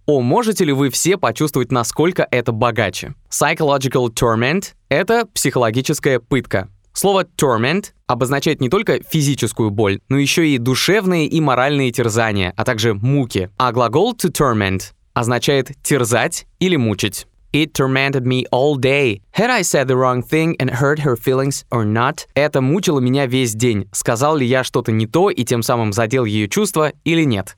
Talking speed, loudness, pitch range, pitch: 165 wpm, -17 LUFS, 120-150 Hz, 130 Hz